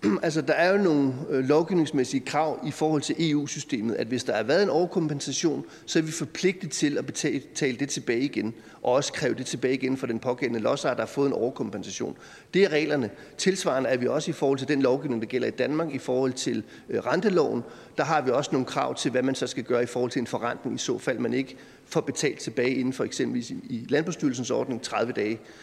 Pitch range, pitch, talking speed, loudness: 130-160 Hz, 145 Hz, 235 wpm, -27 LUFS